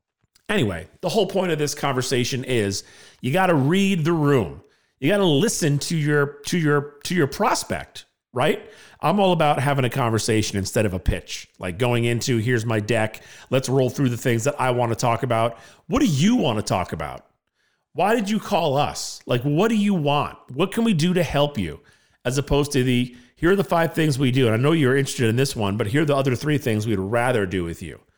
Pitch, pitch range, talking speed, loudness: 135 Hz, 115-155 Hz, 230 wpm, -22 LUFS